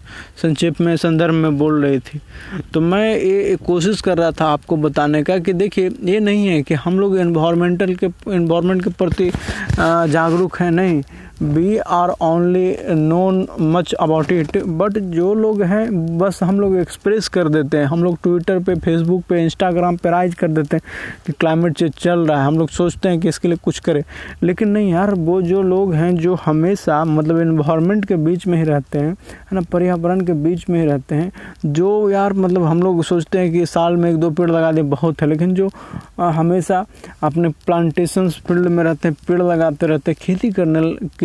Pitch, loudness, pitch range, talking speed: 175 Hz, -16 LUFS, 165-185 Hz, 195 wpm